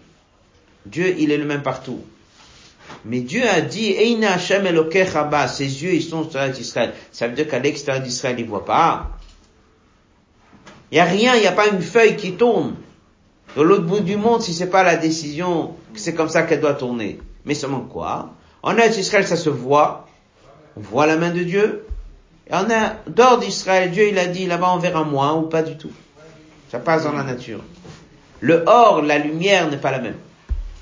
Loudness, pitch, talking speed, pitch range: -18 LUFS, 160 Hz, 195 wpm, 135-190 Hz